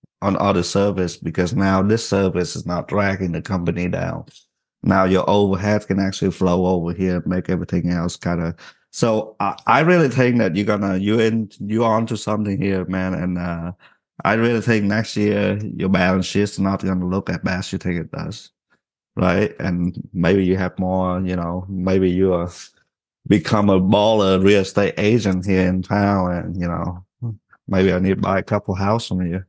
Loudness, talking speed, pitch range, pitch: -19 LUFS, 200 wpm, 90-105 Hz, 95 Hz